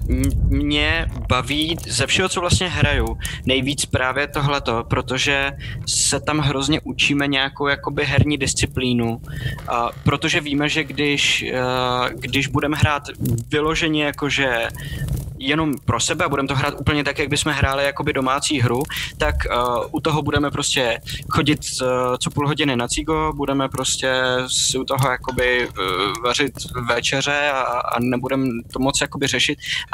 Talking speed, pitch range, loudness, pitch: 140 wpm, 125-145 Hz, -20 LUFS, 140 Hz